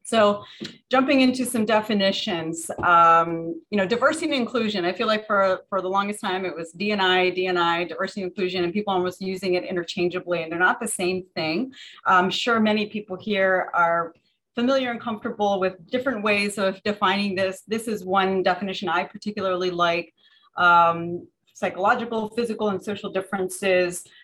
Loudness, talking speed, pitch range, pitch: -23 LUFS, 170 wpm, 180-215 Hz, 190 Hz